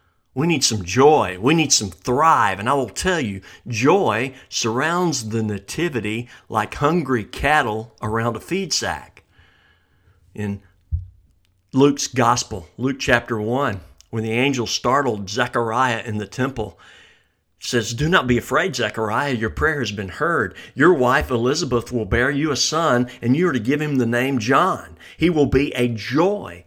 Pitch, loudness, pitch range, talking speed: 120 Hz, -20 LUFS, 105-135 Hz, 160 wpm